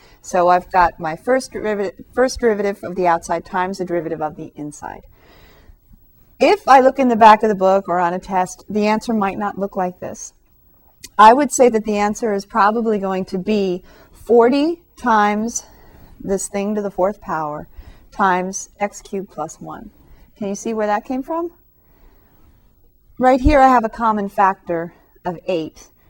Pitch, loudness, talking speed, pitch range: 200 Hz, -17 LUFS, 175 wpm, 180-225 Hz